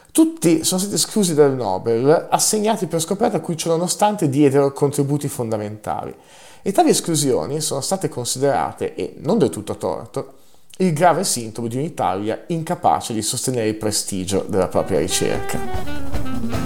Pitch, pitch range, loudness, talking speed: 145 Hz, 115-175 Hz, -20 LUFS, 140 wpm